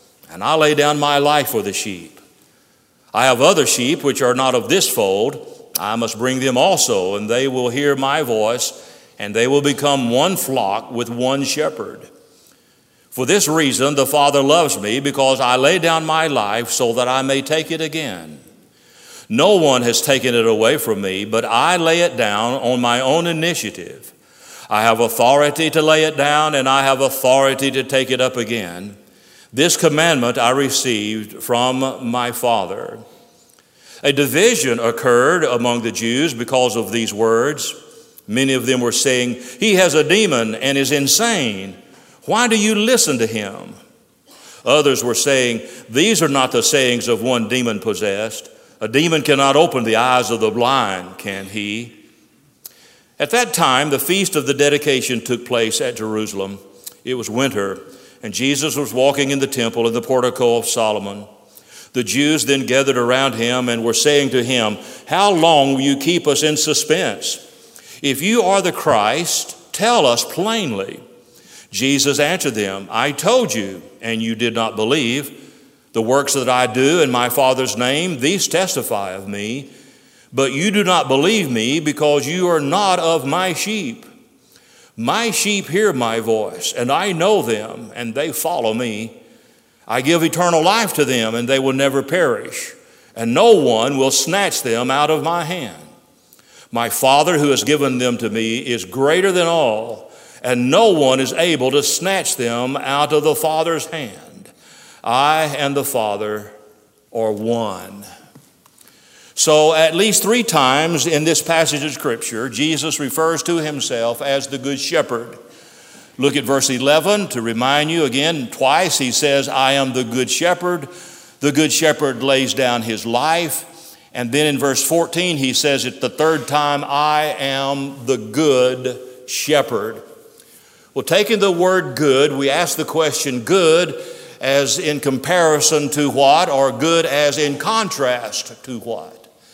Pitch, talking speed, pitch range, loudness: 135 Hz, 165 wpm, 120-155 Hz, -16 LUFS